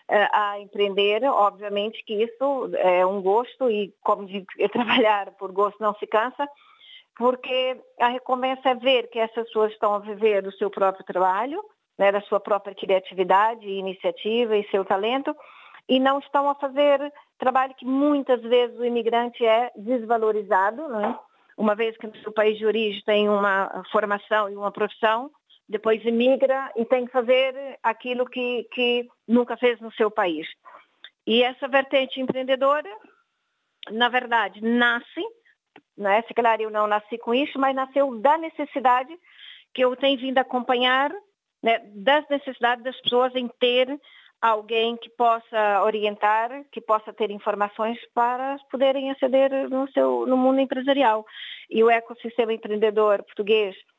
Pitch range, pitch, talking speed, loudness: 210-265 Hz, 235 Hz, 150 wpm, -23 LUFS